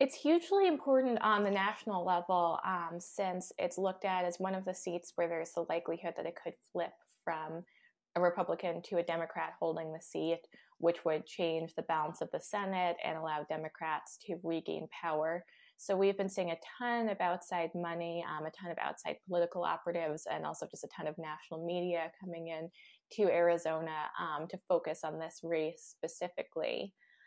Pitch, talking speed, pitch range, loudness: 170 Hz, 185 wpm, 165-185 Hz, -36 LUFS